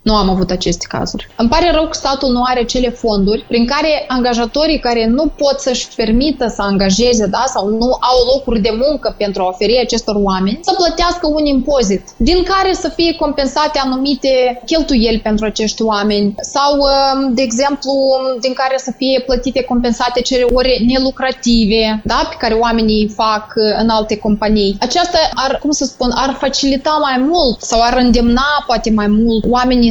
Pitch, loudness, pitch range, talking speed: 250 Hz, -13 LUFS, 225-275 Hz, 175 wpm